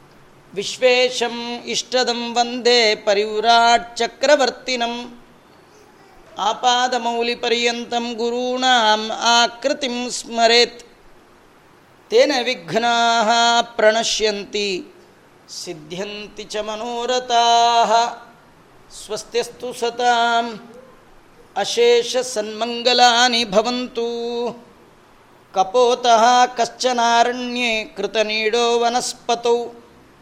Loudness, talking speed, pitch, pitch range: -18 LUFS, 45 wpm, 235 Hz, 230-245 Hz